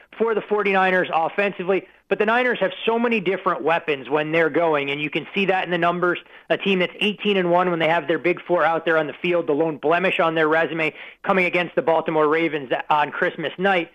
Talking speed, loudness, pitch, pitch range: 235 wpm, -21 LUFS, 175 Hz, 160-190 Hz